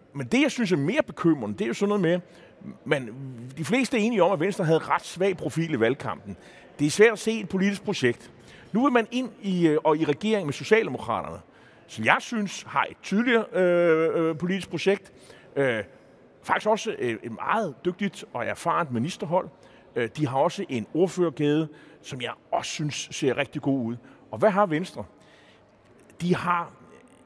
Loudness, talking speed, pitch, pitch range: -25 LUFS, 180 wpm, 175 Hz, 150-205 Hz